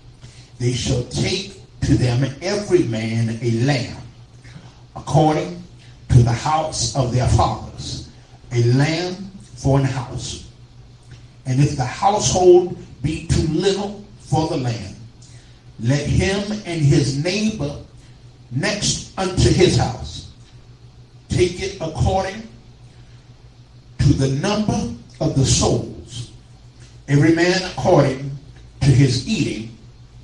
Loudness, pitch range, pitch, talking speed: -19 LUFS, 120-155 Hz, 125 Hz, 110 wpm